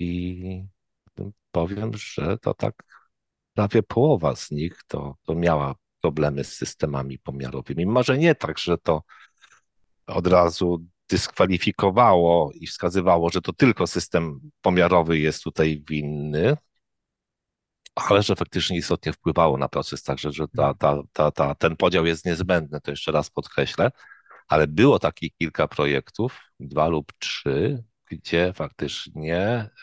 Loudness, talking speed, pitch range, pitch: -23 LUFS, 135 wpm, 75-95 Hz, 85 Hz